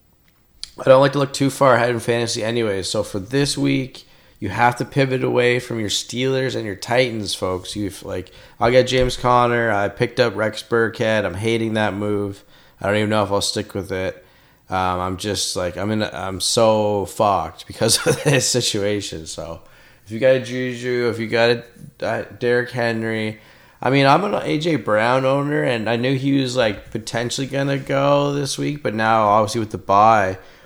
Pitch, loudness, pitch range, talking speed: 115 Hz, -19 LUFS, 105-130 Hz, 200 wpm